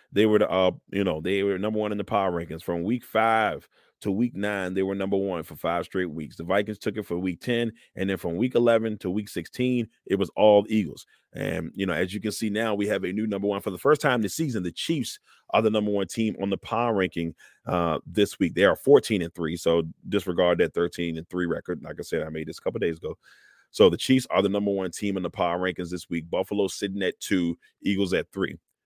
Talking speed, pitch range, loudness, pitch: 260 wpm, 90-105 Hz, -26 LUFS, 100 Hz